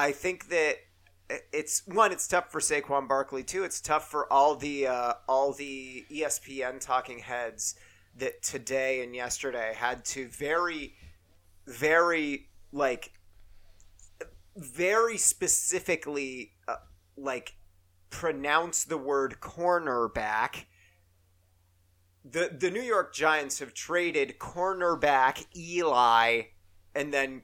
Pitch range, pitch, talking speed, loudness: 110-165 Hz, 135 Hz, 110 wpm, -29 LUFS